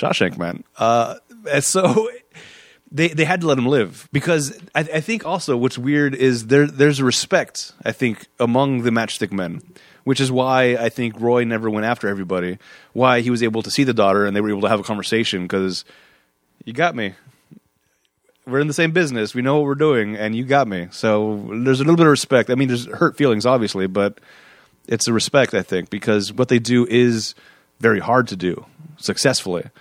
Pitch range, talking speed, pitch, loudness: 105-140 Hz, 205 wpm, 120 Hz, -19 LUFS